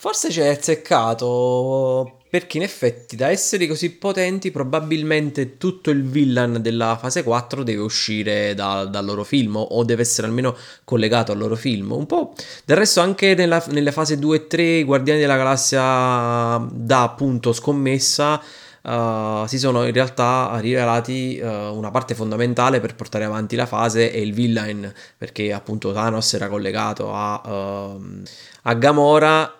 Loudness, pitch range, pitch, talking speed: -19 LUFS, 110-145 Hz, 125 Hz, 155 wpm